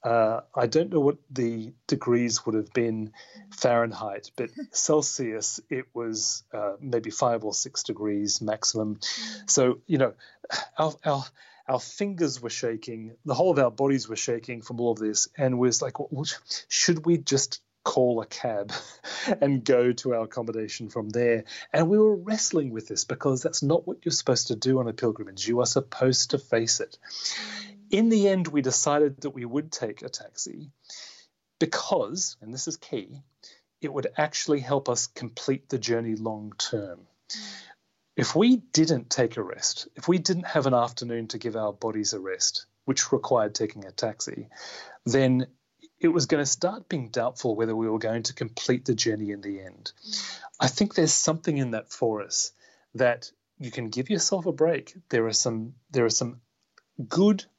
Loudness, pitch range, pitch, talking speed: -26 LUFS, 115-155 Hz, 130 Hz, 180 wpm